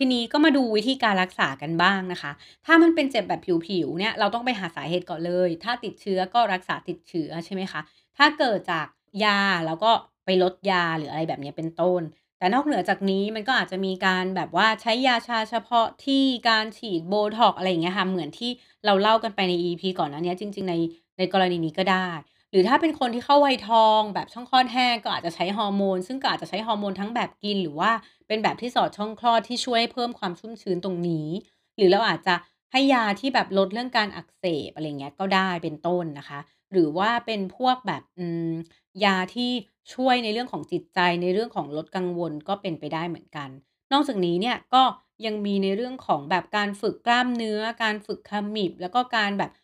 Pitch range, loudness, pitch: 175-230 Hz, -24 LUFS, 195 Hz